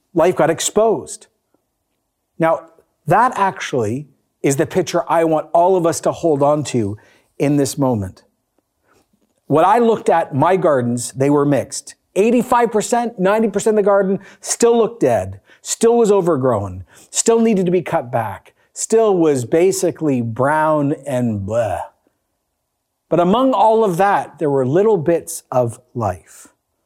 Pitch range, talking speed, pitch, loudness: 130-200 Hz, 145 wpm, 165 Hz, -16 LUFS